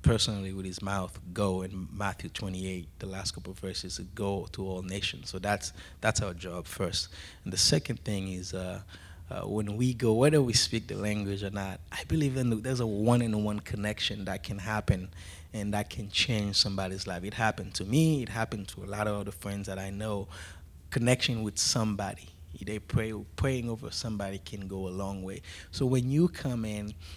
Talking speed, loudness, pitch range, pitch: 200 wpm, -31 LUFS, 95-110 Hz, 100 Hz